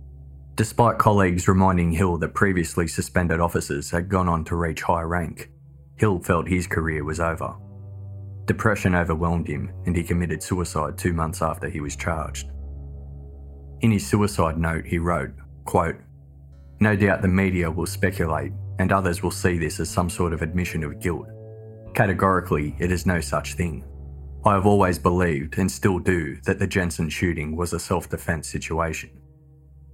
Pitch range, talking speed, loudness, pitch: 75-95 Hz, 160 wpm, -23 LUFS, 85 Hz